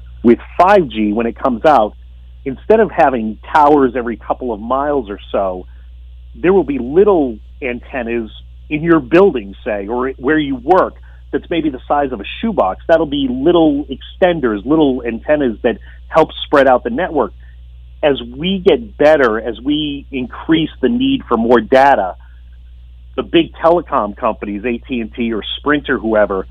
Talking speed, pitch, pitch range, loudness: 155 wpm, 125 Hz, 95-160 Hz, -15 LUFS